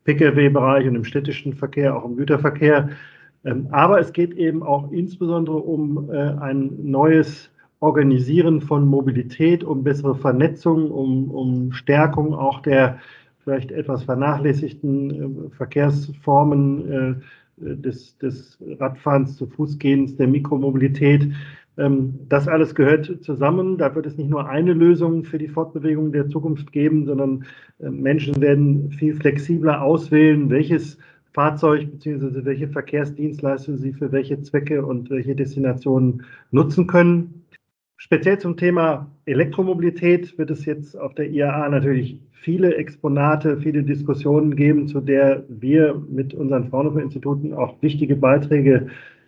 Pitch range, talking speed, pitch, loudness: 135-155 Hz, 130 wpm, 145 Hz, -19 LUFS